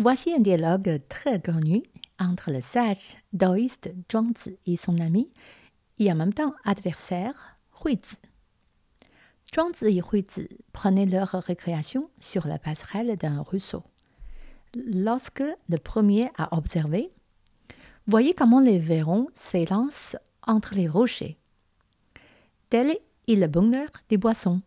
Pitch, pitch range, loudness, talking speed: 200 Hz, 180-235 Hz, -25 LUFS, 120 wpm